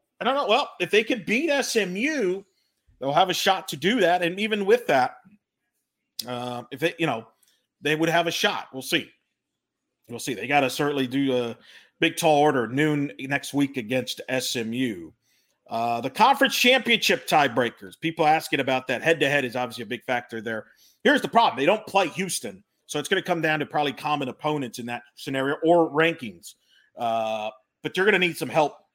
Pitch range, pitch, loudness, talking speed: 125-180 Hz, 150 Hz, -24 LUFS, 200 wpm